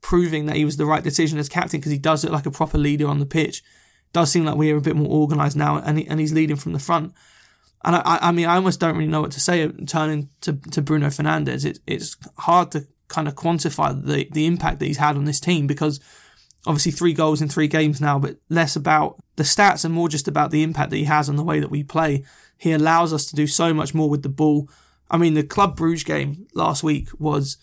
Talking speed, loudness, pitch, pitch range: 260 wpm, -20 LUFS, 155 Hz, 150-165 Hz